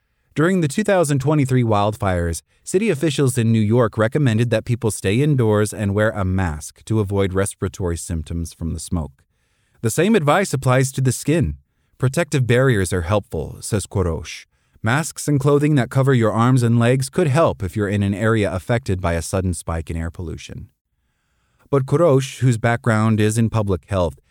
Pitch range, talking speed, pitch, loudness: 95-135 Hz, 175 wpm, 110 Hz, -19 LUFS